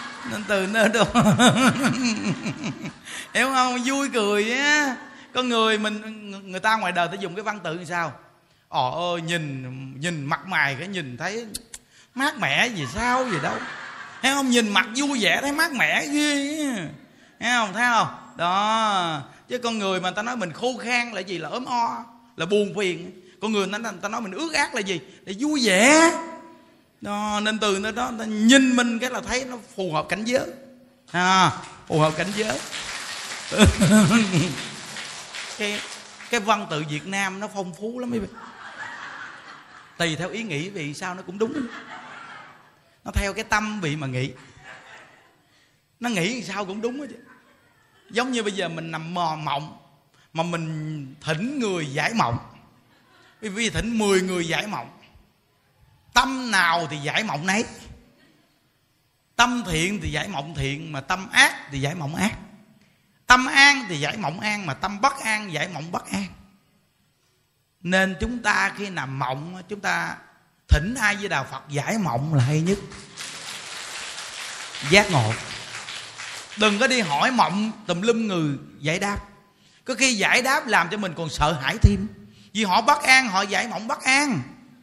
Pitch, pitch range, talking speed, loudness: 205 Hz, 170-240 Hz, 170 wpm, -23 LUFS